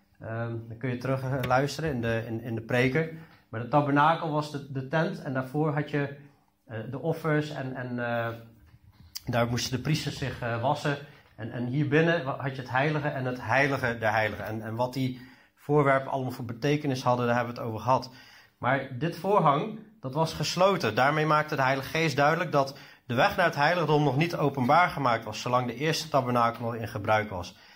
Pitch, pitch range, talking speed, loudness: 135 Hz, 120-150 Hz, 210 wpm, -27 LUFS